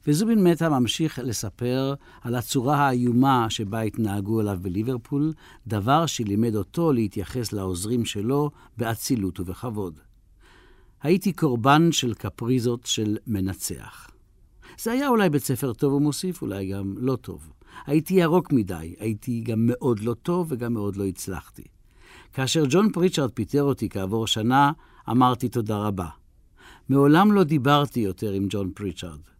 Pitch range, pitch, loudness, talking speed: 105-145 Hz, 120 Hz, -24 LUFS, 135 wpm